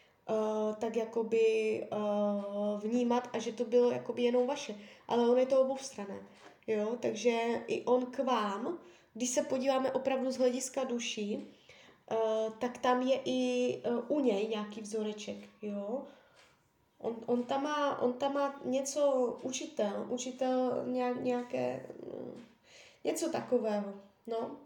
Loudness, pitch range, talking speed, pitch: -33 LUFS, 215-260 Hz, 140 wpm, 245 Hz